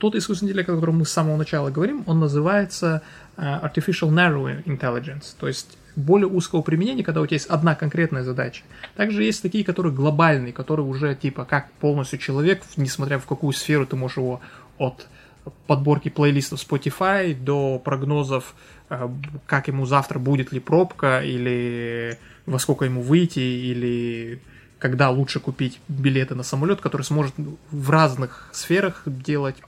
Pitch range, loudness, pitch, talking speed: 135-160 Hz, -22 LUFS, 145 Hz, 155 wpm